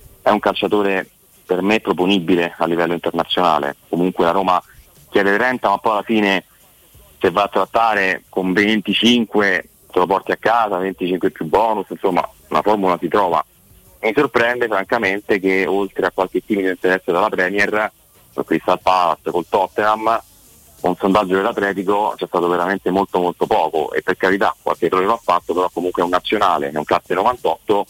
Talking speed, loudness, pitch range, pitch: 170 wpm, -18 LUFS, 90-105 Hz, 95 Hz